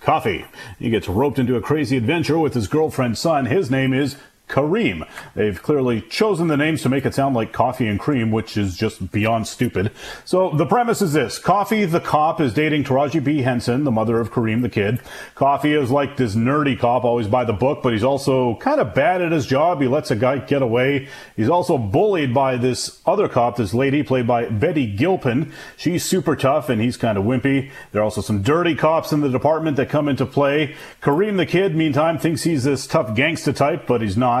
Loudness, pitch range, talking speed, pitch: -19 LUFS, 120-150 Hz, 220 wpm, 135 Hz